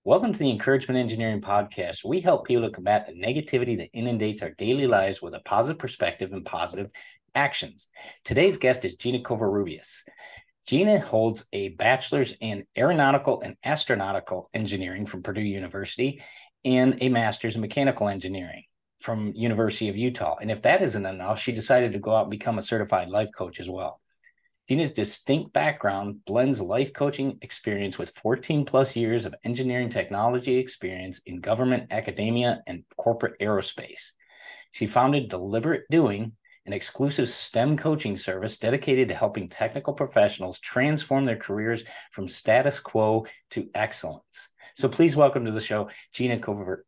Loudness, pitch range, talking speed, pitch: -26 LUFS, 105-130 Hz, 155 wpm, 115 Hz